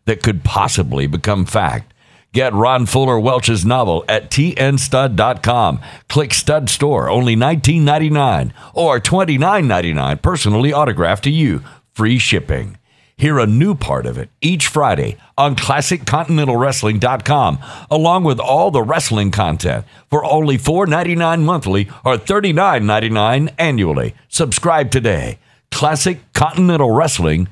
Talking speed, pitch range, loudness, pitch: 140 wpm, 110-150 Hz, -15 LUFS, 130 Hz